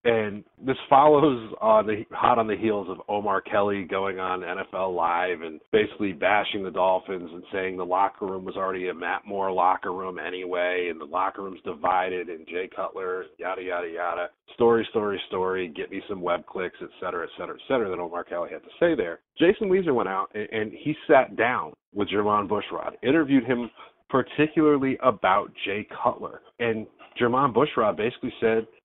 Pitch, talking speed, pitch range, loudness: 105 Hz, 185 wpm, 95-130 Hz, -25 LUFS